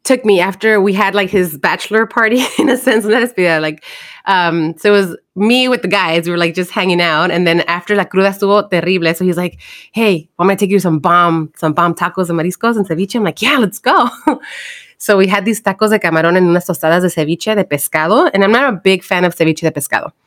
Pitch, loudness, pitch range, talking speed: 190 Hz, -13 LUFS, 170-215 Hz, 245 wpm